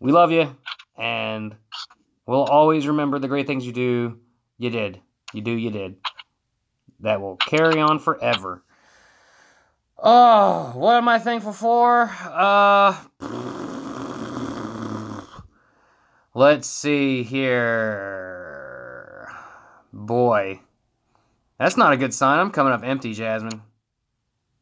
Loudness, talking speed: -20 LUFS, 105 wpm